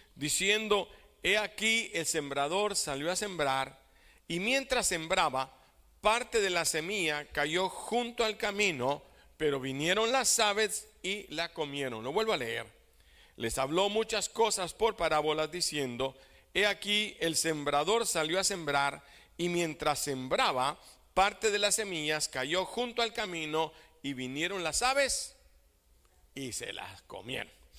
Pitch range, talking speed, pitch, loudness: 145-210 Hz, 135 wpm, 175 Hz, -31 LUFS